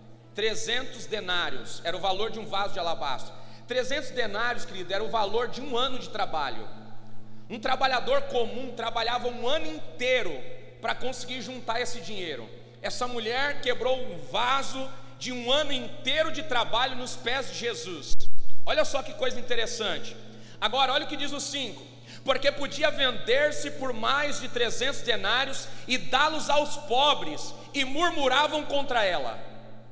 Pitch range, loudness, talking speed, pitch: 220-280 Hz, -28 LUFS, 150 wpm, 250 Hz